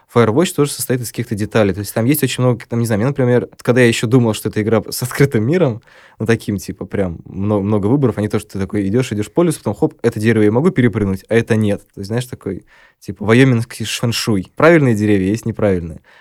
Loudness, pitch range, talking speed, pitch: -16 LUFS, 105-125 Hz, 240 wpm, 115 Hz